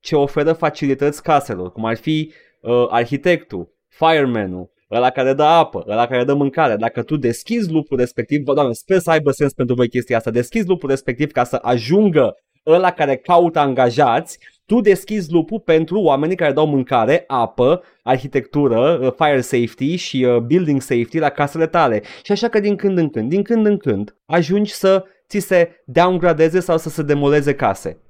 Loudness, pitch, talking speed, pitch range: -17 LUFS, 145 Hz, 180 wpm, 130-175 Hz